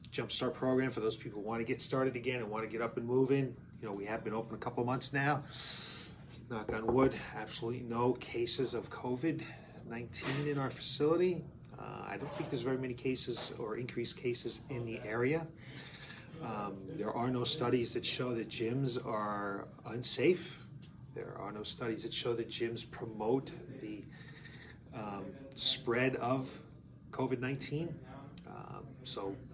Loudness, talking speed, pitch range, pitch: -37 LUFS, 165 wpm, 115-135 Hz, 125 Hz